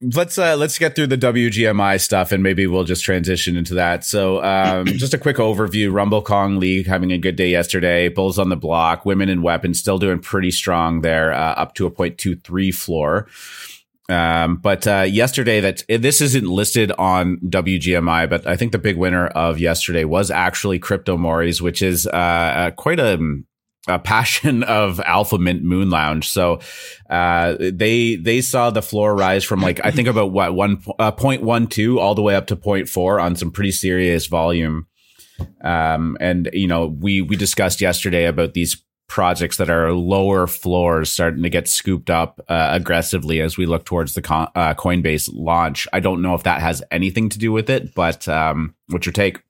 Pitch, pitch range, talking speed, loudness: 95 Hz, 85-100 Hz, 190 wpm, -18 LUFS